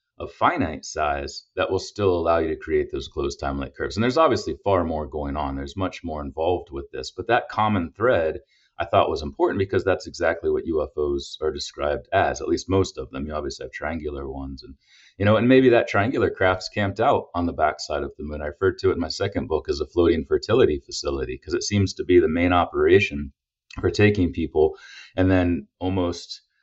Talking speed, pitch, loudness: 215 wpm, 100 Hz, -23 LUFS